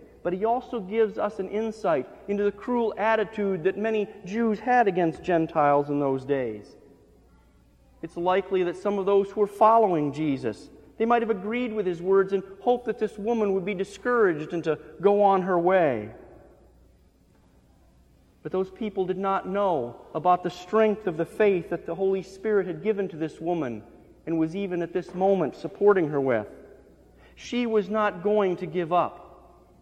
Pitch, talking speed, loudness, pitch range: 190 Hz, 175 wpm, -25 LUFS, 165-210 Hz